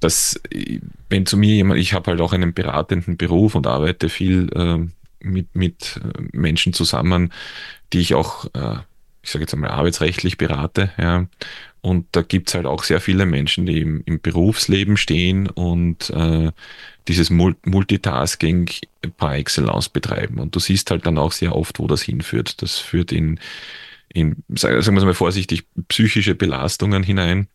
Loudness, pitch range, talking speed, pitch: -19 LUFS, 85-95 Hz, 165 wpm, 90 Hz